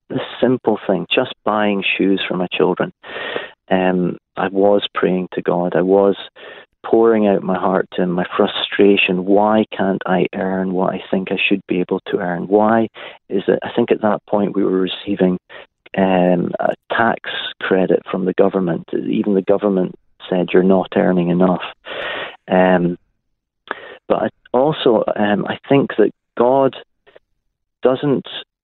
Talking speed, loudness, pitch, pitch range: 155 wpm, -17 LUFS, 95 Hz, 90-100 Hz